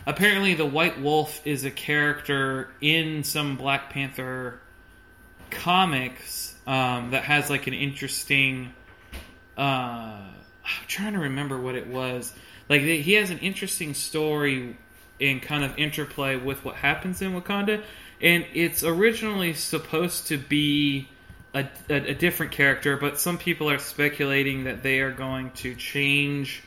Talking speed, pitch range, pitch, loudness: 140 wpm, 130-155 Hz, 140 Hz, -24 LUFS